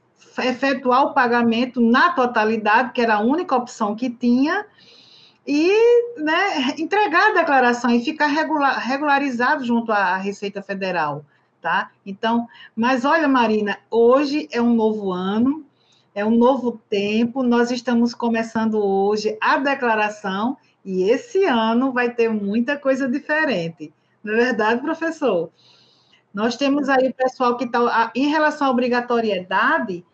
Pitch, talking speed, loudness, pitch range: 245 Hz, 130 wpm, -19 LUFS, 220-275 Hz